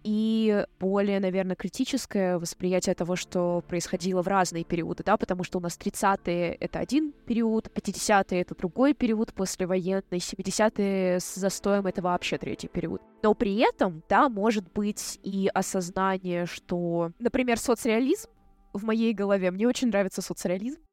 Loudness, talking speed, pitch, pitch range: -27 LUFS, 145 wpm, 195 Hz, 180-220 Hz